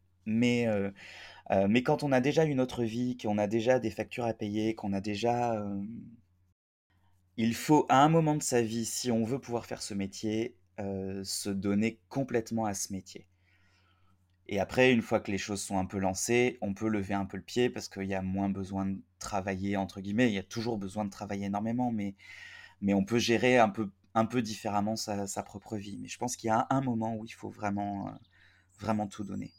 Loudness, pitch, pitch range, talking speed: -31 LUFS, 105 Hz, 95-115 Hz, 225 wpm